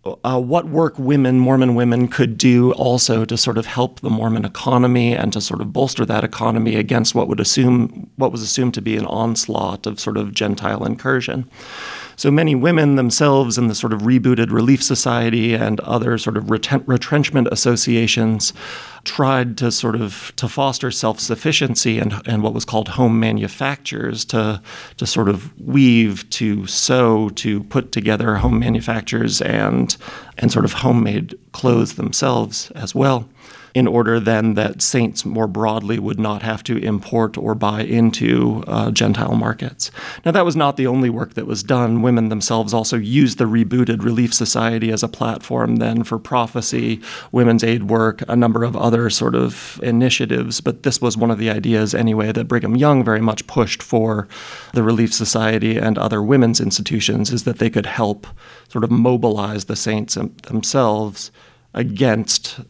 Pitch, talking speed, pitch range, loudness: 115 Hz, 170 wpm, 110-125 Hz, -17 LUFS